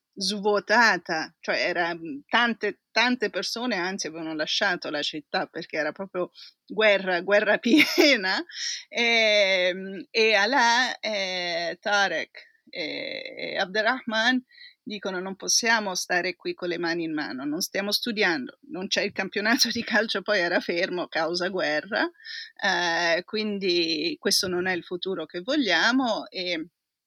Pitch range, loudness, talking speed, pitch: 180-240 Hz, -24 LUFS, 125 wpm, 205 Hz